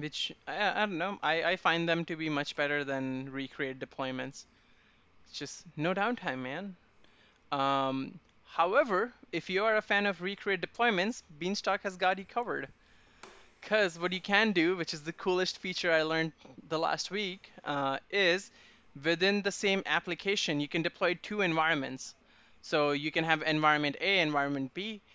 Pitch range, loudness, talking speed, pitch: 145-195 Hz, -31 LUFS, 165 wpm, 170 Hz